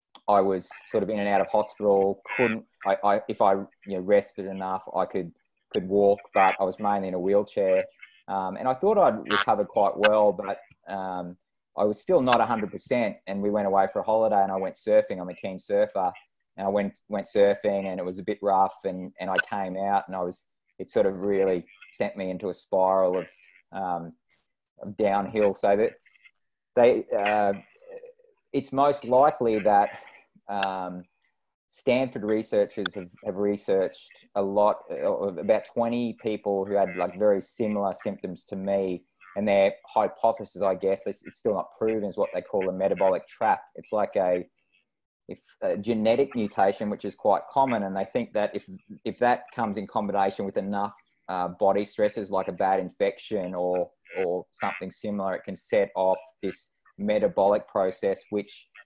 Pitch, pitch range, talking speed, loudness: 100 Hz, 95-110 Hz, 185 wpm, -26 LUFS